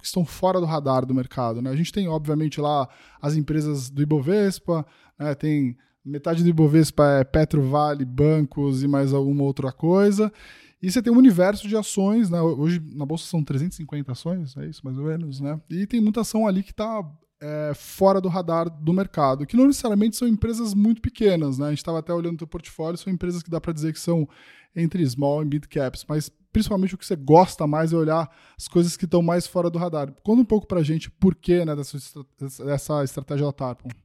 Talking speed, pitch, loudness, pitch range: 215 wpm, 160 Hz, -22 LUFS, 145-185 Hz